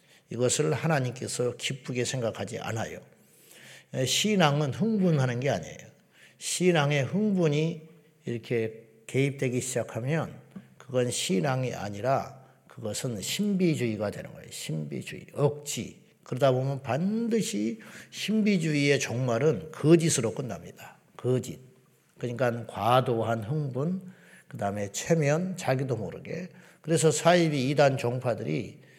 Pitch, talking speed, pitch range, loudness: 135 Hz, 275 characters per minute, 120-160 Hz, -28 LUFS